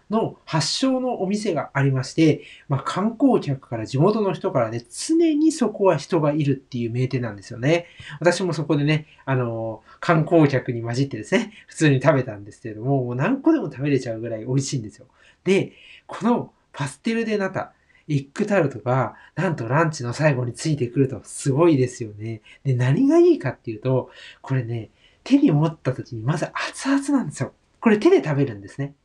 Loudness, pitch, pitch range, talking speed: -22 LUFS, 145 Hz, 125-190 Hz, 380 characters per minute